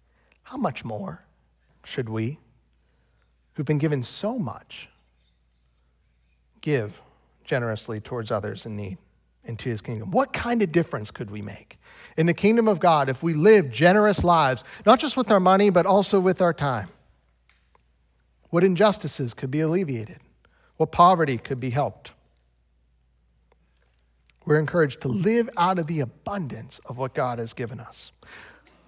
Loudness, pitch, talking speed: -23 LUFS, 125 Hz, 145 wpm